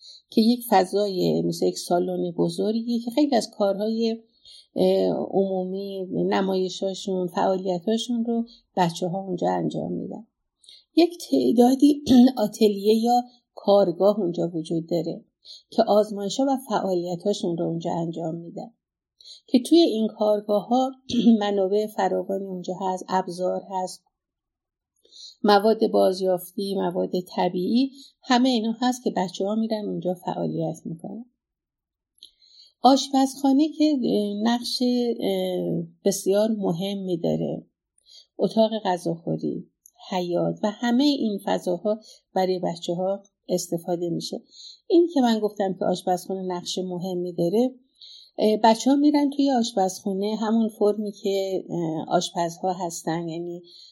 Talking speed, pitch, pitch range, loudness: 110 wpm, 200 Hz, 180-235 Hz, -24 LUFS